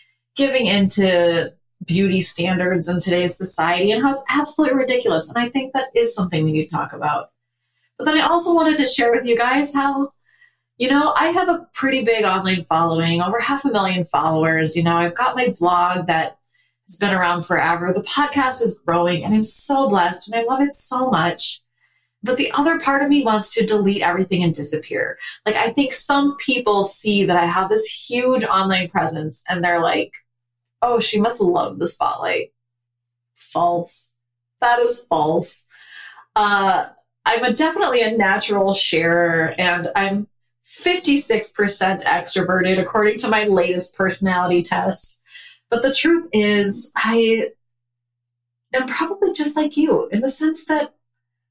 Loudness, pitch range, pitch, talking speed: -18 LUFS, 170-255 Hz, 200 Hz, 165 wpm